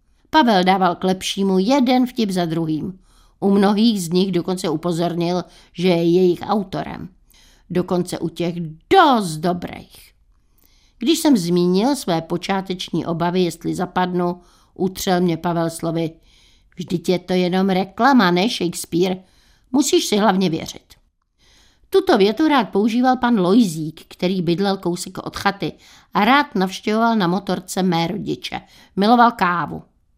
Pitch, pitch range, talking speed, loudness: 185 Hz, 175-205 Hz, 130 wpm, -19 LUFS